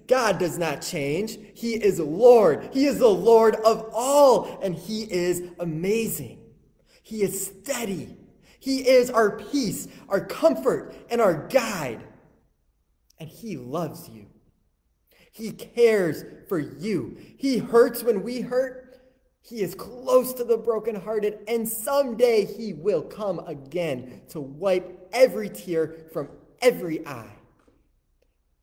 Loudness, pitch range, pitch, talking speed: -23 LUFS, 175-240 Hz, 215 Hz, 130 wpm